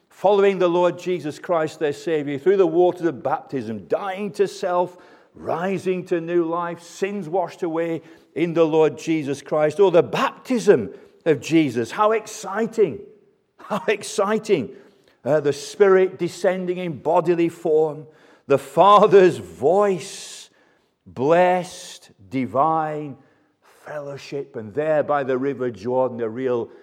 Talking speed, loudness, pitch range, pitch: 130 wpm, -21 LUFS, 150-190 Hz, 170 Hz